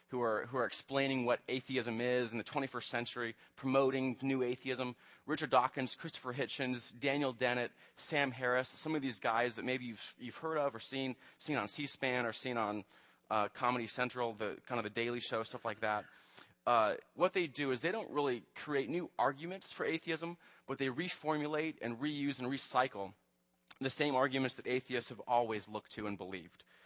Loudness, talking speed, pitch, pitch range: -37 LUFS, 190 wpm, 130 Hz, 120-140 Hz